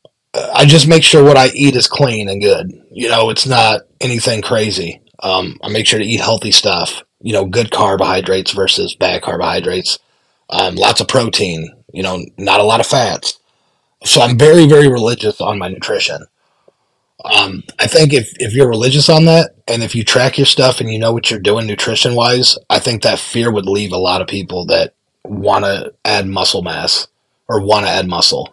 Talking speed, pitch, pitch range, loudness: 200 wpm, 115 Hz, 105-135 Hz, -11 LUFS